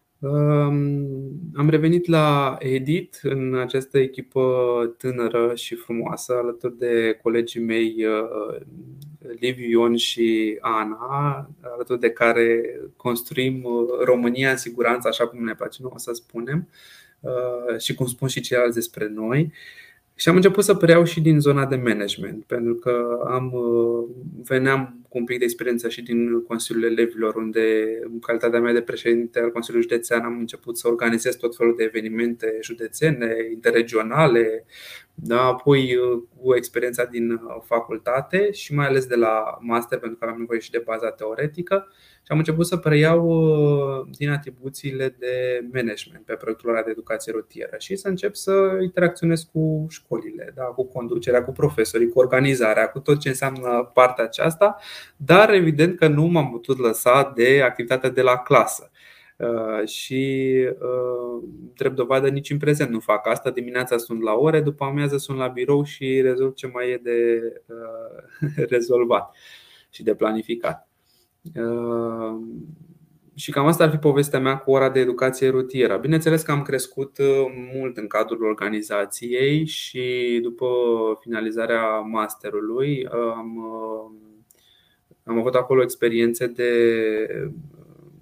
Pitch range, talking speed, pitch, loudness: 115-140 Hz, 140 wpm, 125 Hz, -21 LUFS